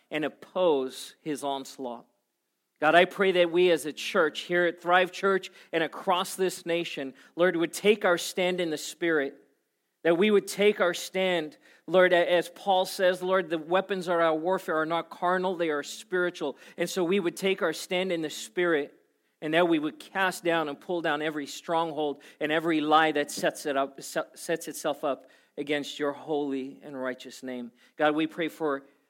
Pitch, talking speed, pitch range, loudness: 170 Hz, 190 wpm, 150-180 Hz, -27 LUFS